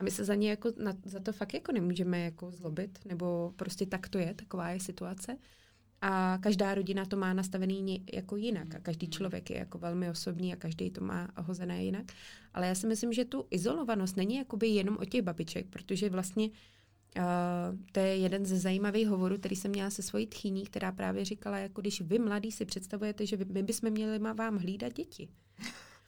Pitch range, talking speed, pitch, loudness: 180-210 Hz, 205 wpm, 195 Hz, -35 LUFS